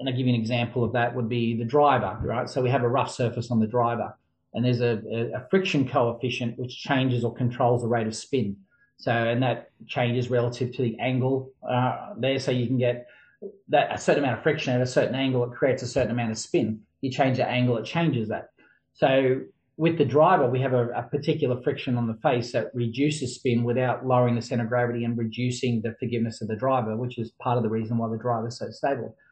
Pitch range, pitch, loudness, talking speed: 120-130 Hz, 125 Hz, -25 LUFS, 235 wpm